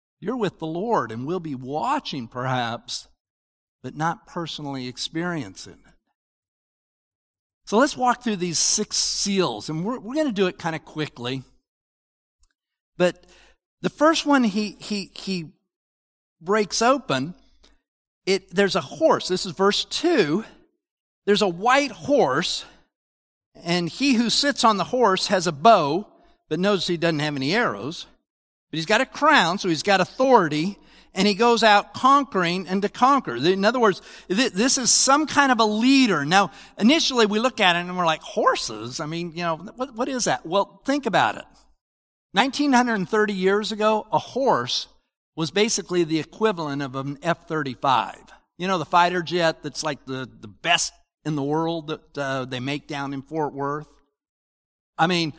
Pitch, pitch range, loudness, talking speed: 180 Hz, 150-220 Hz, -22 LUFS, 170 wpm